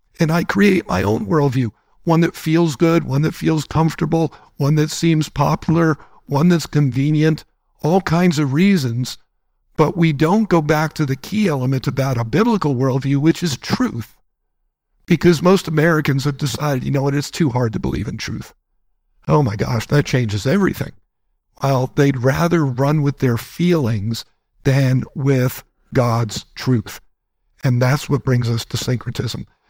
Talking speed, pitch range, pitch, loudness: 160 wpm, 130-165 Hz, 145 Hz, -18 LUFS